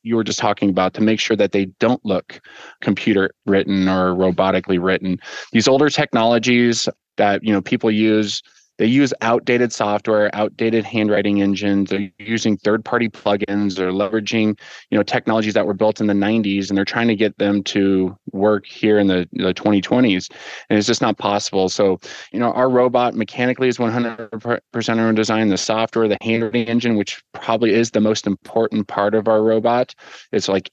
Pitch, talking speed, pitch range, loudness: 110 Hz, 180 wpm, 100-115 Hz, -18 LUFS